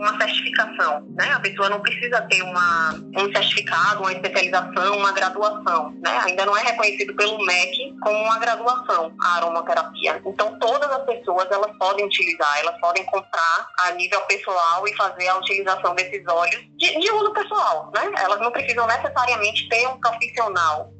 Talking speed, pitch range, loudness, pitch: 165 wpm, 185-235 Hz, -20 LUFS, 205 Hz